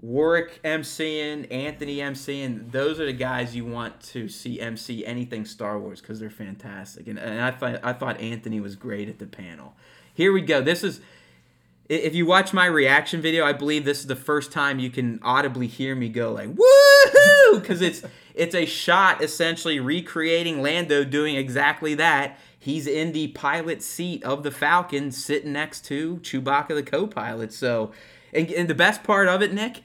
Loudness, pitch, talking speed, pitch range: -21 LUFS, 145 Hz, 185 wpm, 120-165 Hz